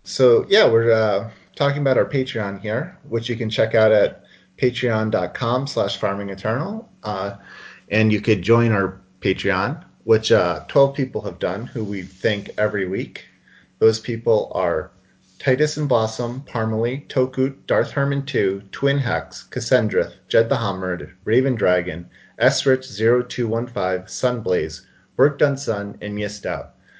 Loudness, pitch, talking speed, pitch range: -21 LUFS, 115 Hz, 135 wpm, 100-130 Hz